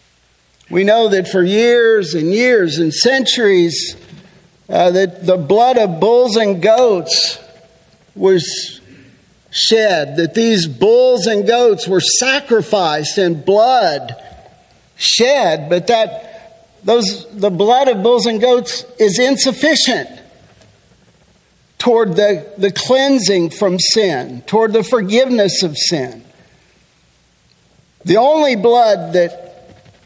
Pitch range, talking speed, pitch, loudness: 175-235 Hz, 110 wpm, 205 Hz, -13 LUFS